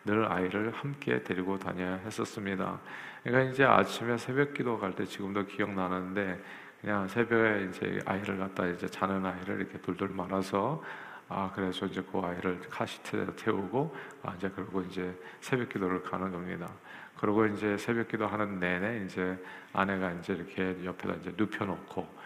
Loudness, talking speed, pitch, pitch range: -33 LUFS, 360 characters per minute, 95 Hz, 95-105 Hz